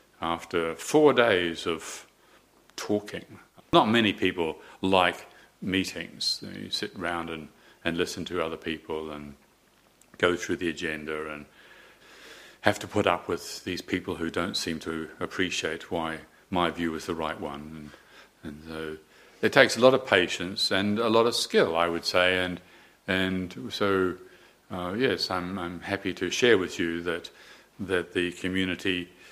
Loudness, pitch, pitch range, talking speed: -27 LUFS, 90 Hz, 80-95 Hz, 160 wpm